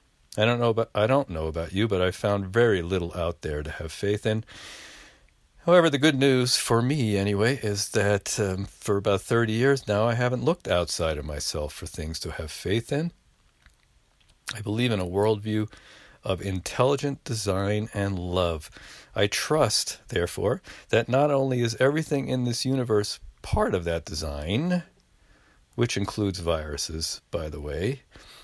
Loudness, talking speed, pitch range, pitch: -26 LUFS, 165 wpm, 90-125 Hz, 105 Hz